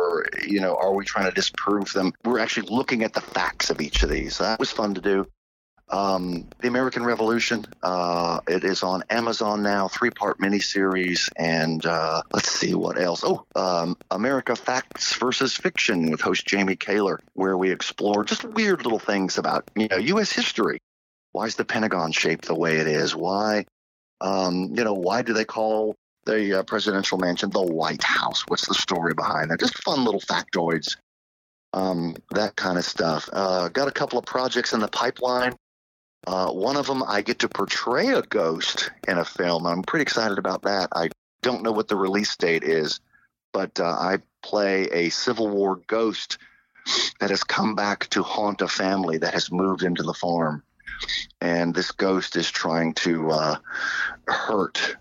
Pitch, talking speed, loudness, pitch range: 95 Hz, 180 wpm, -24 LUFS, 85-110 Hz